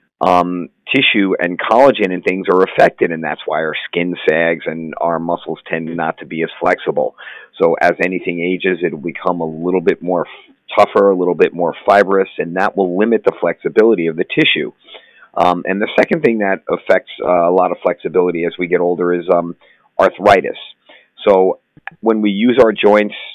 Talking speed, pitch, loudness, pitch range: 195 wpm, 90 Hz, -15 LUFS, 85-100 Hz